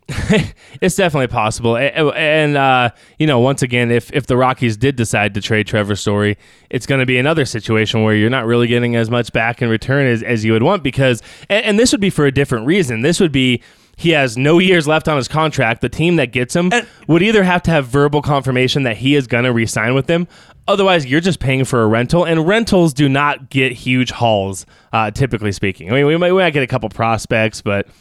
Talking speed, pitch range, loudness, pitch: 235 wpm, 115-155 Hz, -15 LUFS, 130 Hz